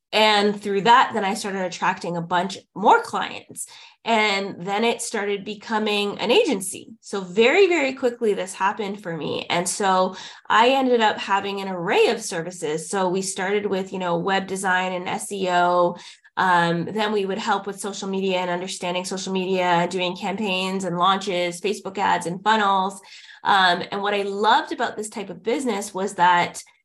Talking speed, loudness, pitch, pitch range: 175 wpm, -22 LUFS, 195 Hz, 185-210 Hz